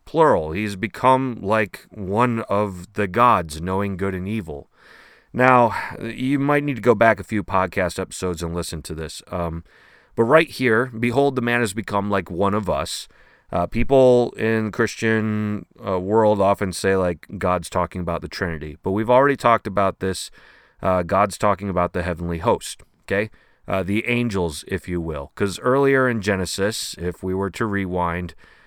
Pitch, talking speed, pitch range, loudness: 100 Hz, 175 wpm, 90-115 Hz, -21 LUFS